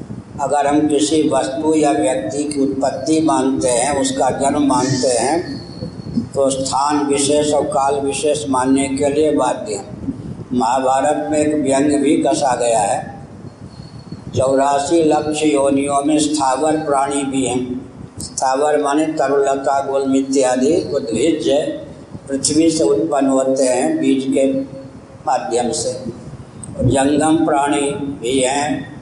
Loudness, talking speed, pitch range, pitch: -16 LUFS, 125 wpm, 135-150 Hz, 140 Hz